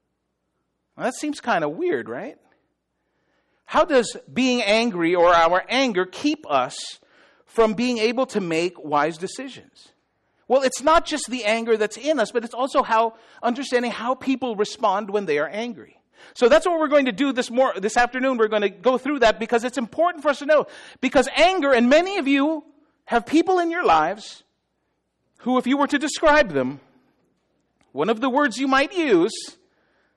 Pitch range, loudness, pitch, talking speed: 220-295 Hz, -21 LUFS, 255 Hz, 185 wpm